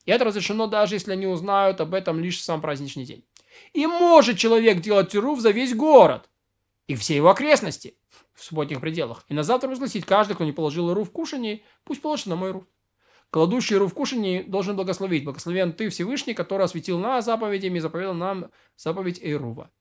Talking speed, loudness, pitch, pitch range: 190 wpm, -22 LUFS, 195 Hz, 175-225 Hz